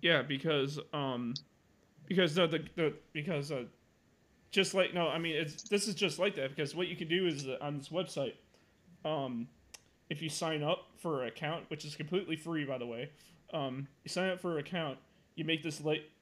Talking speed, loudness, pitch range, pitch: 205 wpm, -36 LUFS, 145-175 Hz, 160 Hz